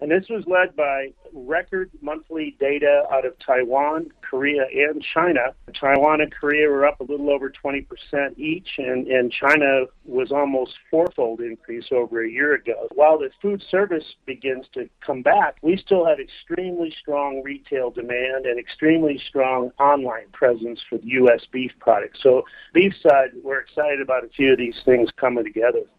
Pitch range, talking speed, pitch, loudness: 130-160 Hz, 170 wpm, 140 Hz, -21 LUFS